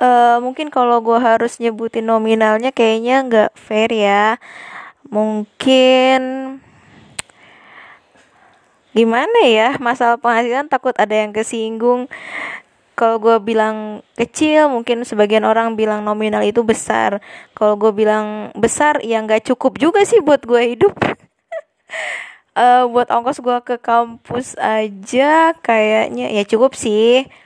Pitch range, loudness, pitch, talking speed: 220-260 Hz, -15 LUFS, 235 Hz, 120 wpm